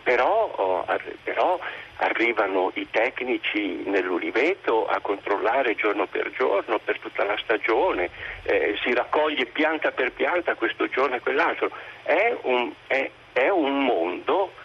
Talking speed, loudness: 125 wpm, -24 LUFS